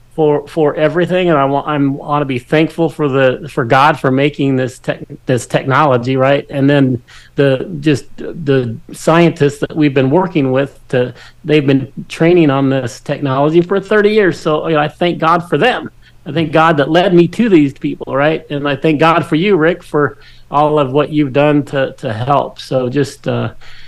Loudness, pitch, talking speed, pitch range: -13 LUFS, 145 Hz, 200 wpm, 135-160 Hz